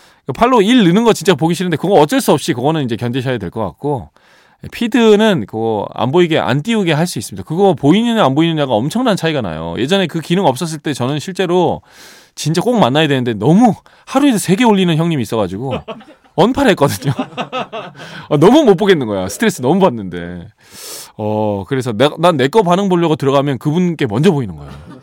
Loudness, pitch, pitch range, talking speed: -14 LUFS, 160 Hz, 130-195 Hz, 395 characters per minute